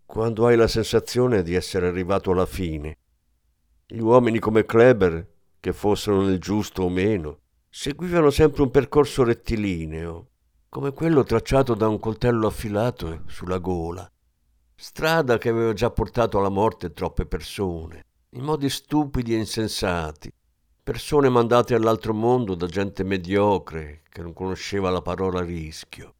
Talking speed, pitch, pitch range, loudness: 135 wpm, 100 Hz, 85-115 Hz, -22 LUFS